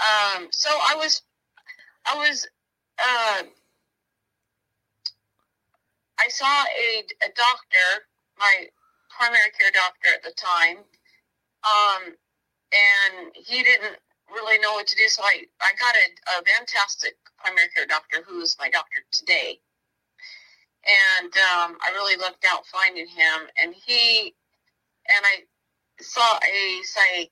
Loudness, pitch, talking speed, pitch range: -20 LUFS, 205 Hz, 125 wpm, 185-245 Hz